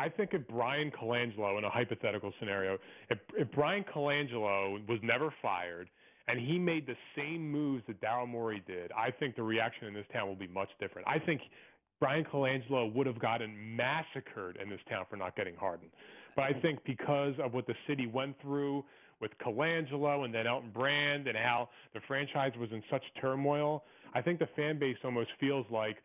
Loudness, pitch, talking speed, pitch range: -35 LUFS, 130 Hz, 195 wpm, 115-145 Hz